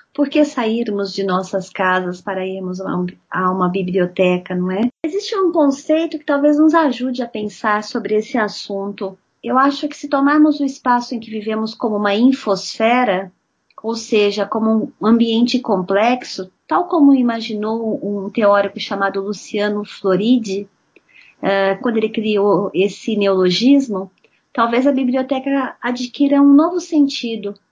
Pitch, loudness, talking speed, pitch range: 220 Hz, -17 LUFS, 140 wpm, 195-265 Hz